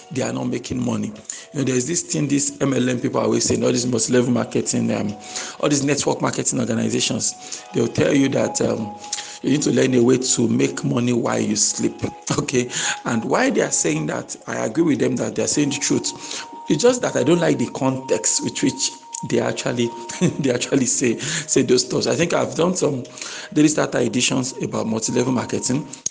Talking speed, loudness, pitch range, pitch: 205 wpm, -20 LUFS, 120-145 Hz, 130 Hz